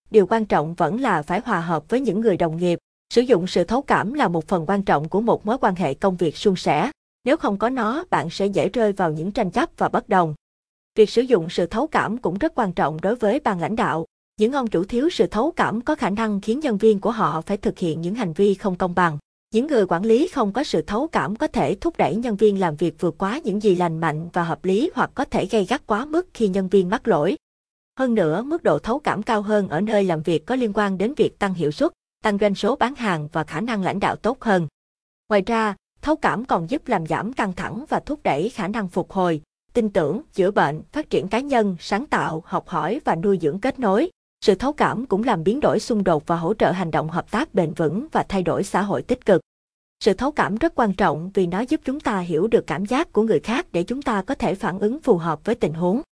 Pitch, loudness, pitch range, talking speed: 210 Hz, -22 LUFS, 180-235 Hz, 260 wpm